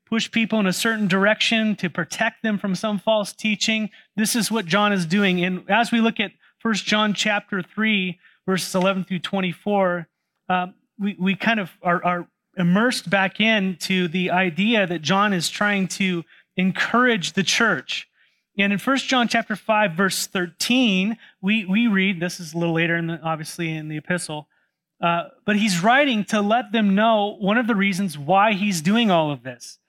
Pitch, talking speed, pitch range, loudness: 200 Hz, 185 wpm, 180-220 Hz, -21 LUFS